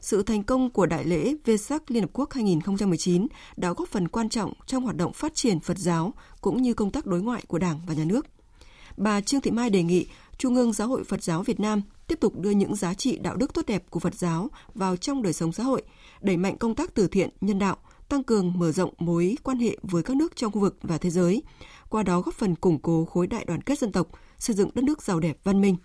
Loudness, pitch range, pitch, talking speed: -26 LUFS, 175-240 Hz, 200 Hz, 260 wpm